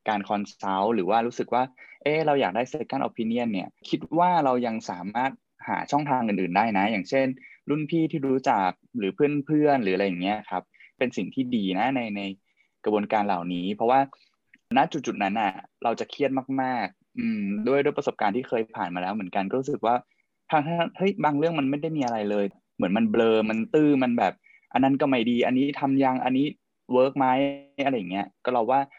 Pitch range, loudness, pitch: 115-150 Hz, -25 LUFS, 135 Hz